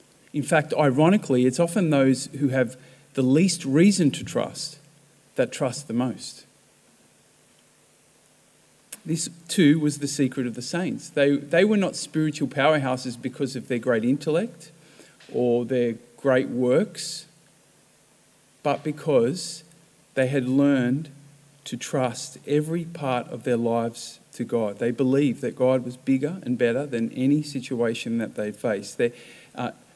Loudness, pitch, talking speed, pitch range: -24 LUFS, 140 Hz, 140 wpm, 130-155 Hz